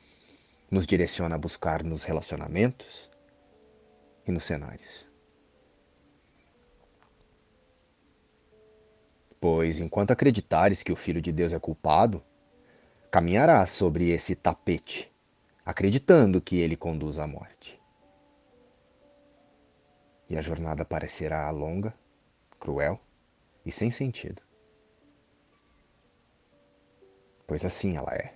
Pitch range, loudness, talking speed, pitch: 75-95 Hz, -27 LUFS, 90 wpm, 85 Hz